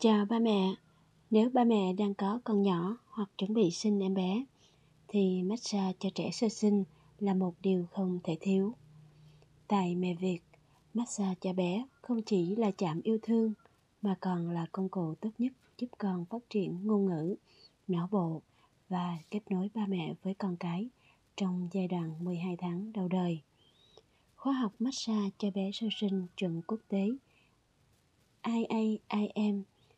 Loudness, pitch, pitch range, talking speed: -33 LUFS, 195 Hz, 180-215 Hz, 160 wpm